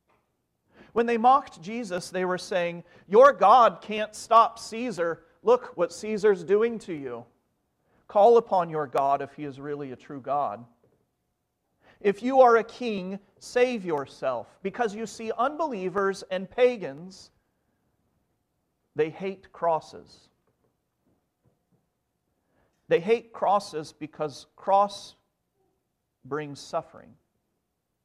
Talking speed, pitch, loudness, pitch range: 110 wpm, 195 Hz, -25 LUFS, 165-230 Hz